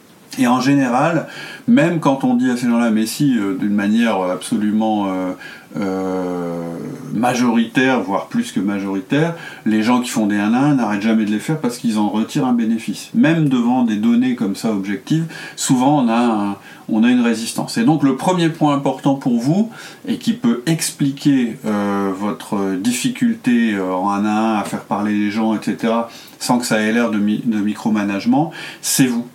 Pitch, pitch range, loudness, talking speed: 120 Hz, 105-165 Hz, -17 LUFS, 190 wpm